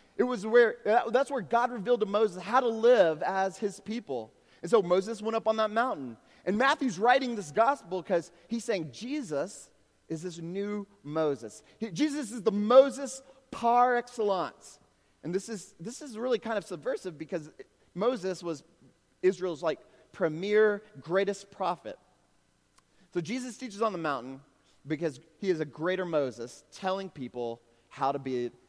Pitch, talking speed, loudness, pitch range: 195 Hz, 165 wpm, -30 LUFS, 160-235 Hz